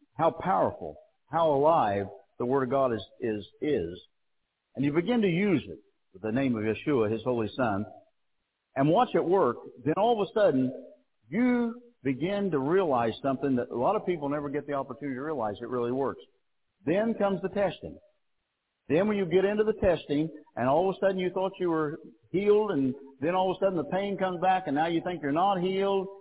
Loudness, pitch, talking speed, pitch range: -28 LUFS, 165 Hz, 210 wpm, 135-195 Hz